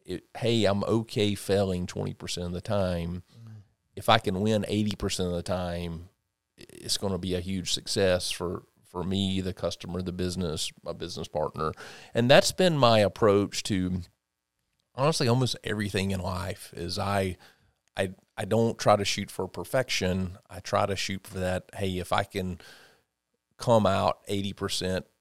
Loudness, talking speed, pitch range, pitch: -28 LUFS, 160 wpm, 90-105 Hz, 95 Hz